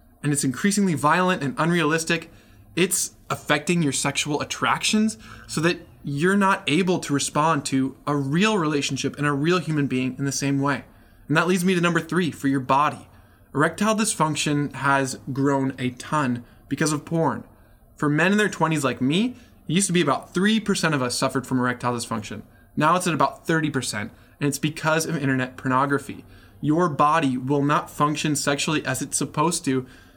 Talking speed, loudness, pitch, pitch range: 180 wpm, -23 LUFS, 145 Hz, 130-165 Hz